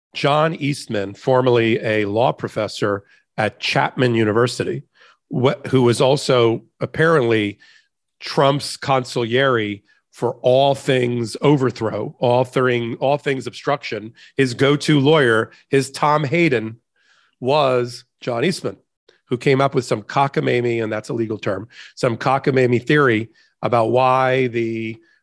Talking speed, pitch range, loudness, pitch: 120 wpm, 115-140 Hz, -19 LUFS, 125 Hz